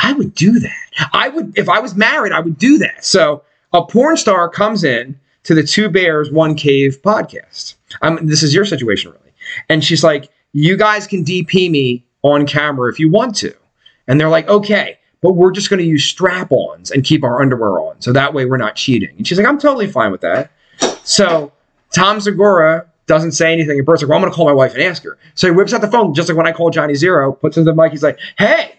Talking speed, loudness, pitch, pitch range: 240 wpm, -13 LUFS, 165 Hz, 150-205 Hz